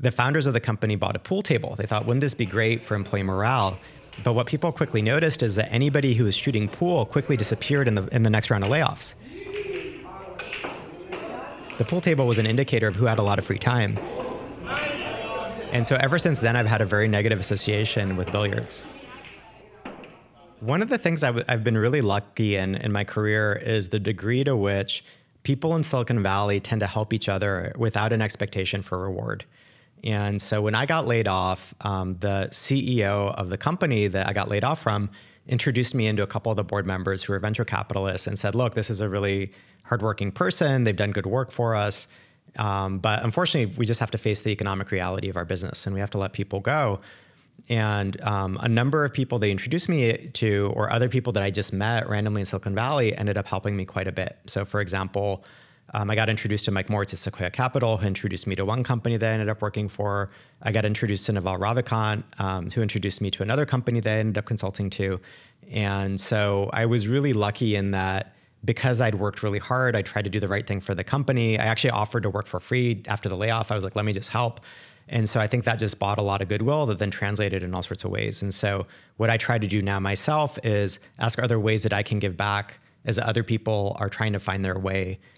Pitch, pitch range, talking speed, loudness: 110 Hz, 100-120 Hz, 230 wpm, -25 LUFS